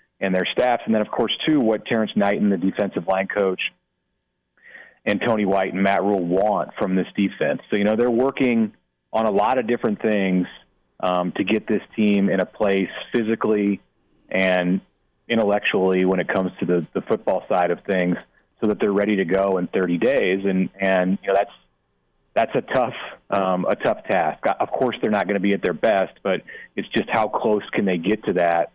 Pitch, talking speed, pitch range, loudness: 95 Hz, 205 wpm, 90-105 Hz, -21 LUFS